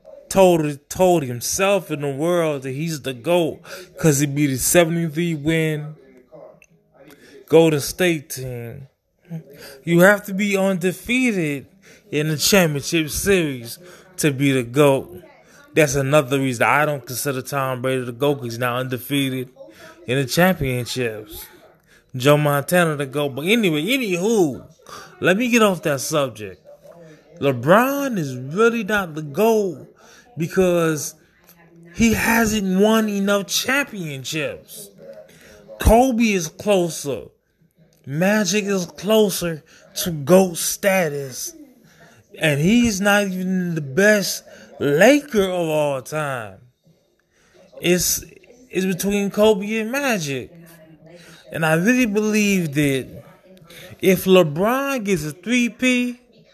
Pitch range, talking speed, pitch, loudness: 145-200 Hz, 115 wpm, 170 Hz, -19 LUFS